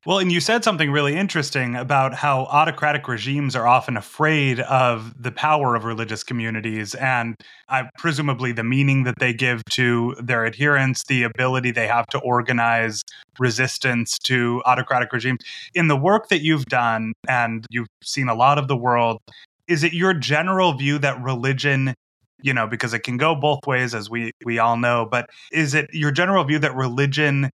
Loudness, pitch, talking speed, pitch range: -20 LUFS, 130 Hz, 180 wpm, 120-145 Hz